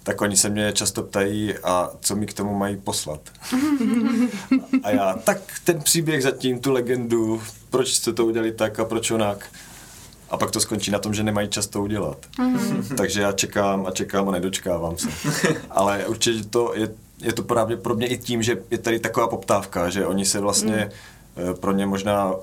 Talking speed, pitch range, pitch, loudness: 190 wpm, 100-120 Hz, 110 Hz, -22 LUFS